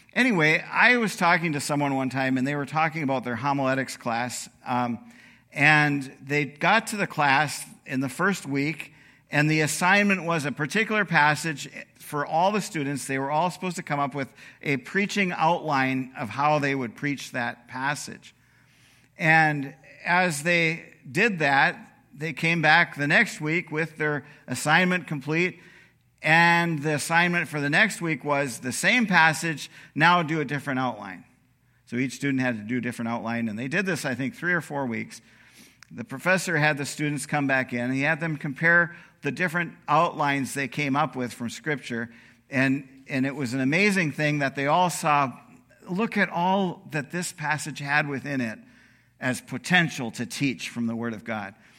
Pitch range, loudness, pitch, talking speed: 130-170 Hz, -24 LUFS, 145 Hz, 180 wpm